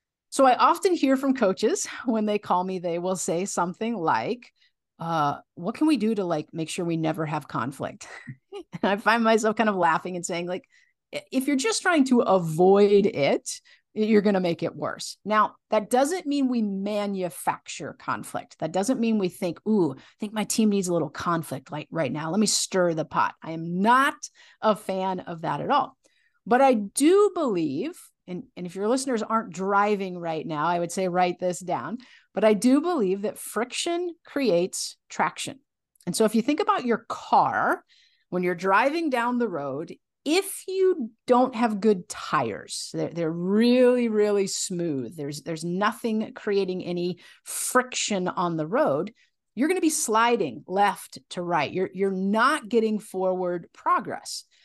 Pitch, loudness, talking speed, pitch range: 210 Hz, -25 LUFS, 180 wpm, 180-260 Hz